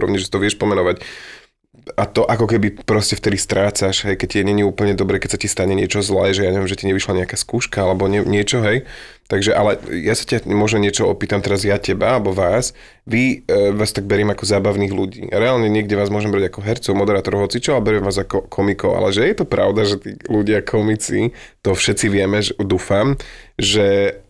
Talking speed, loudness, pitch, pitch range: 210 wpm, -17 LUFS, 100 Hz, 100-105 Hz